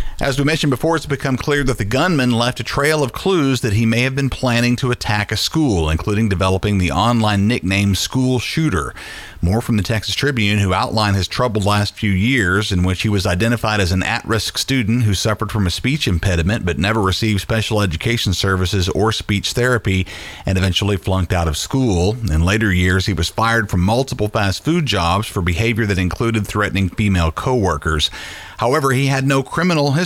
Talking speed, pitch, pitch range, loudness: 200 wpm, 110 Hz, 95-125 Hz, -17 LUFS